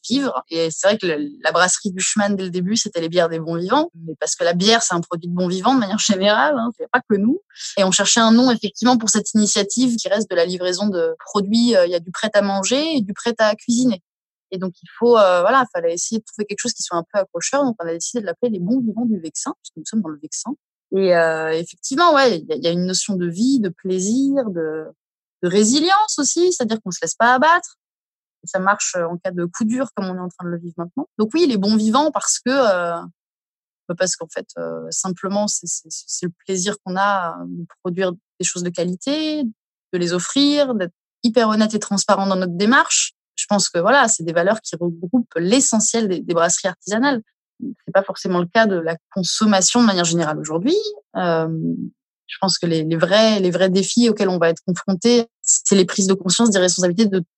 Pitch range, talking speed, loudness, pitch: 175-235 Hz, 235 wpm, -18 LUFS, 195 Hz